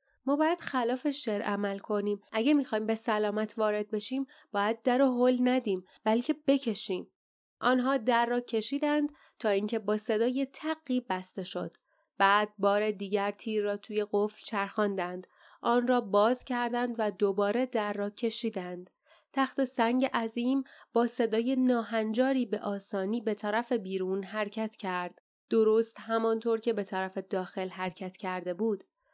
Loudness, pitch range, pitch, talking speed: -30 LUFS, 205-250 Hz, 220 Hz, 140 wpm